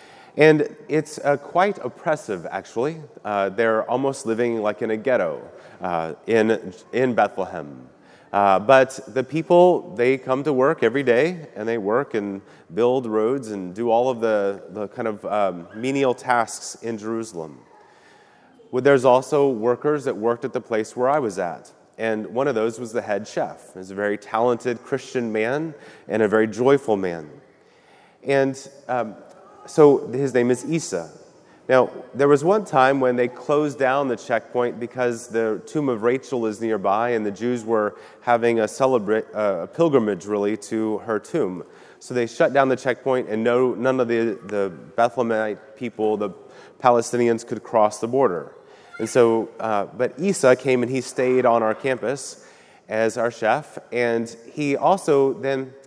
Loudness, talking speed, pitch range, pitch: -22 LUFS, 170 wpm, 110-135 Hz, 120 Hz